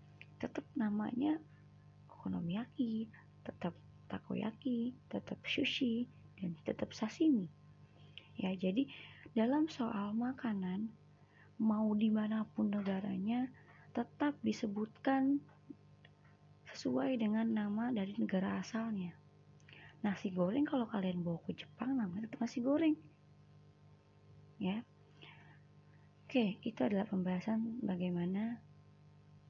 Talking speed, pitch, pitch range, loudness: 85 wpm, 215 Hz, 175-235 Hz, -38 LUFS